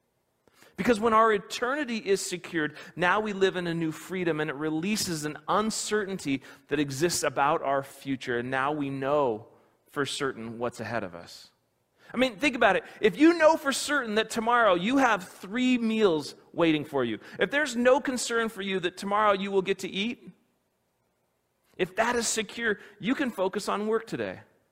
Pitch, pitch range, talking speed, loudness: 195 Hz, 150-225 Hz, 180 wpm, -27 LUFS